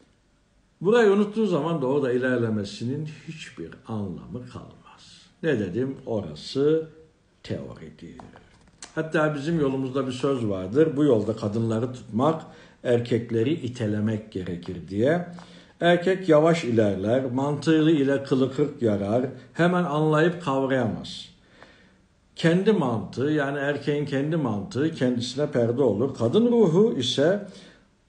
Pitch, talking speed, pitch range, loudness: 140 Hz, 105 wpm, 115-160 Hz, -24 LUFS